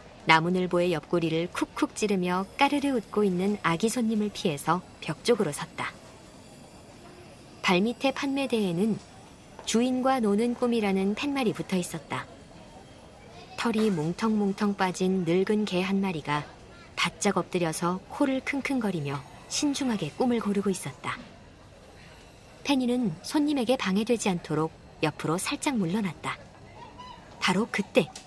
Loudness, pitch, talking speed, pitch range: -28 LUFS, 200 Hz, 270 characters per minute, 175-240 Hz